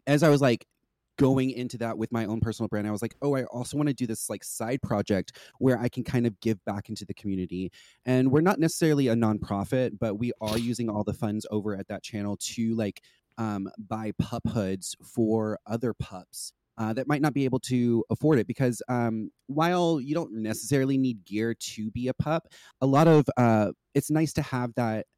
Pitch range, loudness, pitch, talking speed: 110-135 Hz, -27 LUFS, 115 Hz, 215 wpm